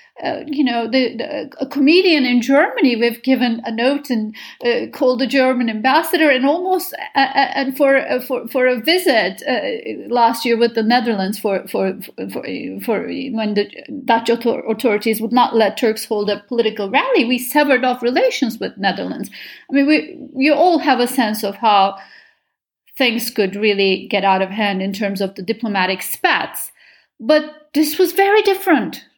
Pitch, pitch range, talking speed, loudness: 250 Hz, 225-290 Hz, 175 wpm, -17 LUFS